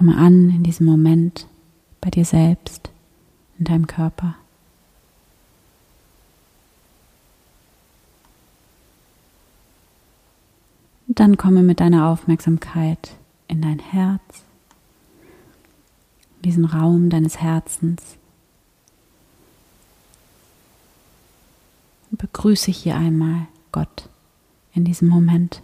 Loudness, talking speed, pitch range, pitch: -17 LUFS, 75 wpm, 155-175 Hz, 165 Hz